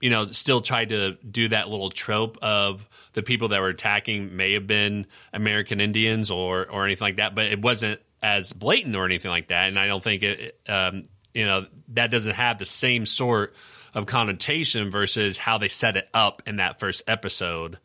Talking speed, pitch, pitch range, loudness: 200 wpm, 105 Hz, 95-115 Hz, -23 LUFS